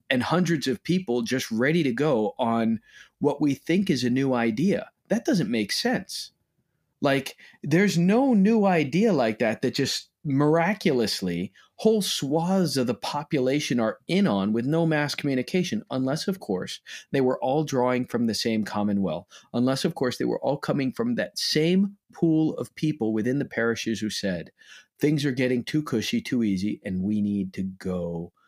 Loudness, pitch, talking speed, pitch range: -25 LUFS, 140 Hz, 175 wpm, 120-170 Hz